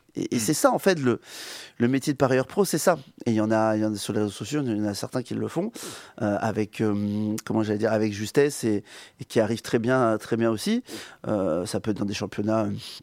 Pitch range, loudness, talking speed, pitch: 105-130 Hz, -25 LUFS, 260 wpm, 110 Hz